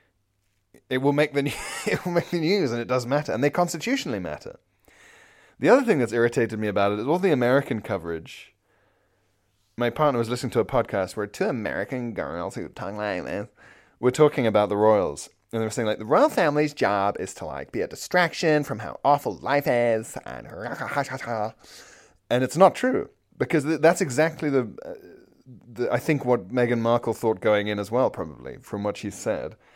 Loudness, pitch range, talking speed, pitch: -24 LUFS, 110-150 Hz, 195 wpm, 120 Hz